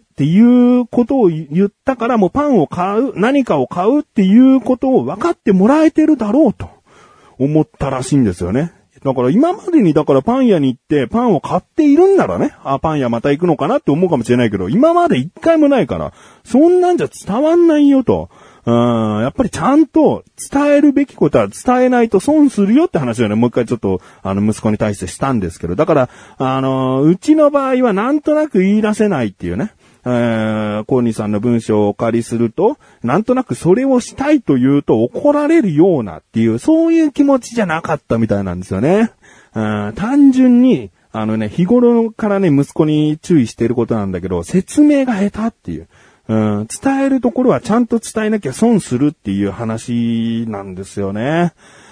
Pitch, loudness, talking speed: 180 Hz, -14 LUFS, 400 characters per minute